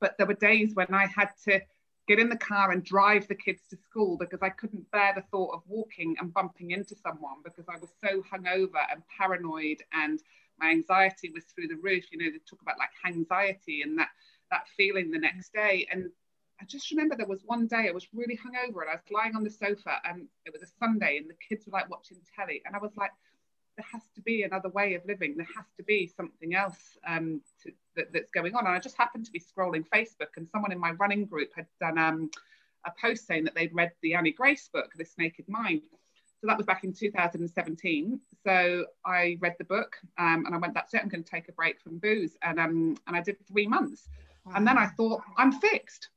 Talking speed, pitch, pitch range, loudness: 240 wpm, 195 Hz, 175-220 Hz, -29 LUFS